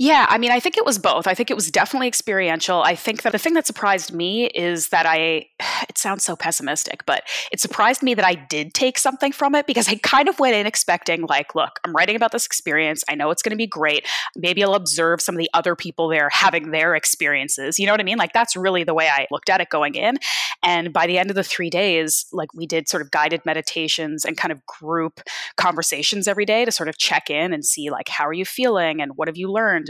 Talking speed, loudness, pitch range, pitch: 255 wpm, -19 LUFS, 160-220 Hz, 180 Hz